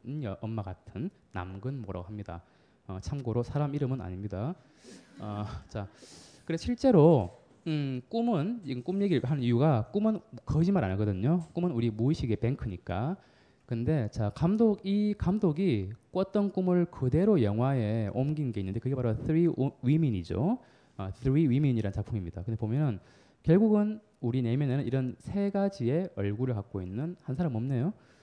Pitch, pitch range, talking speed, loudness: 130 Hz, 110-170 Hz, 340 characters per minute, -30 LUFS